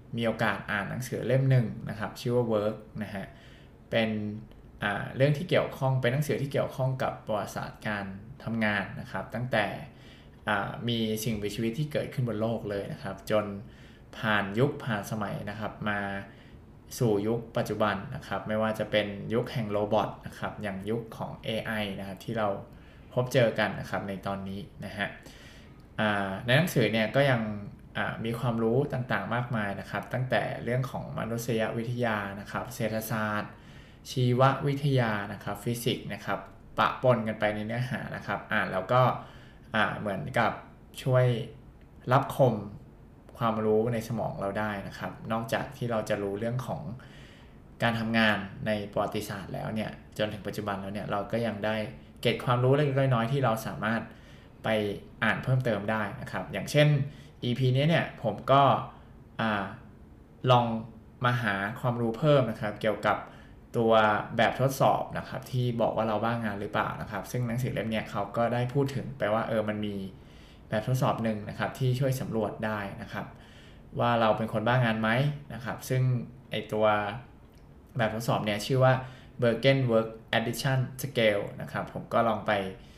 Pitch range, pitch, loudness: 105-125 Hz, 115 Hz, -29 LUFS